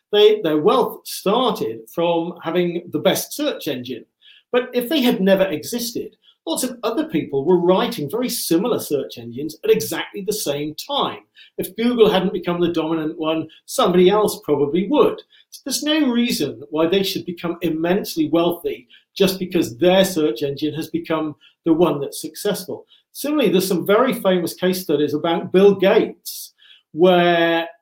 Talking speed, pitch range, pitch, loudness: 160 wpm, 160-220 Hz, 180 Hz, -19 LUFS